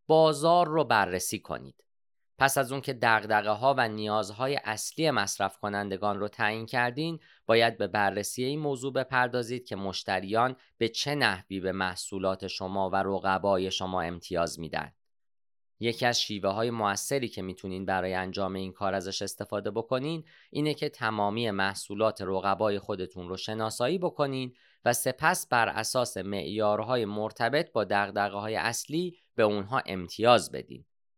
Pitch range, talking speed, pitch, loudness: 95-125 Hz, 140 wpm, 105 Hz, -29 LUFS